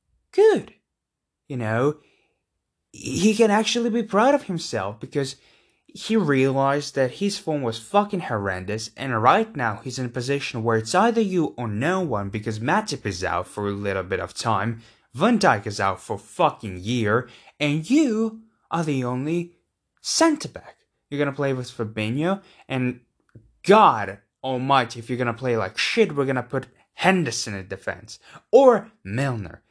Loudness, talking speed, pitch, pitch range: -23 LUFS, 160 wpm, 135 Hz, 115-185 Hz